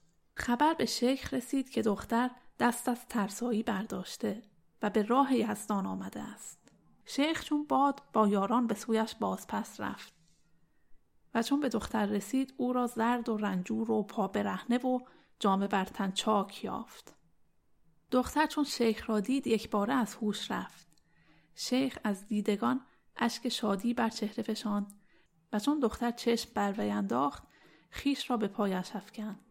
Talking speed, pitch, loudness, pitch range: 145 wpm, 225 Hz, -32 LUFS, 205-250 Hz